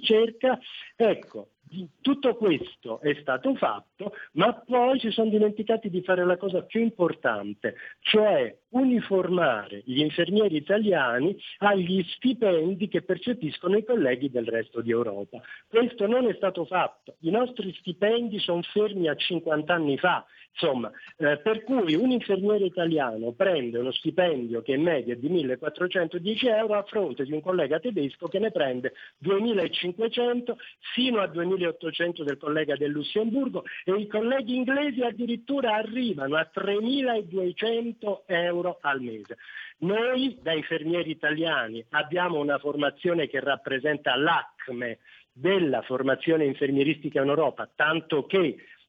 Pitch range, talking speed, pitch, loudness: 150-220 Hz, 135 wpm, 180 Hz, -26 LUFS